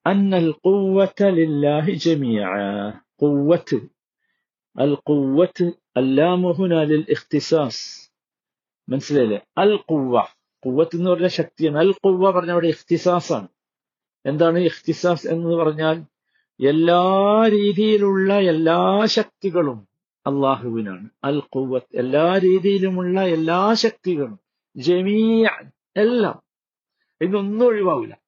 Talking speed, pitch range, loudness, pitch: 90 wpm, 145-190 Hz, -19 LUFS, 170 Hz